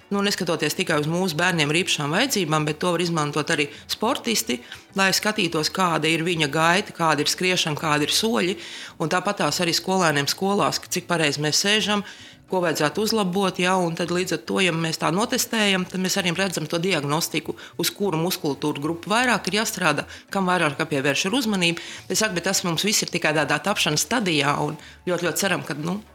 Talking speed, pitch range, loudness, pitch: 160 wpm, 155-195 Hz, -22 LUFS, 175 Hz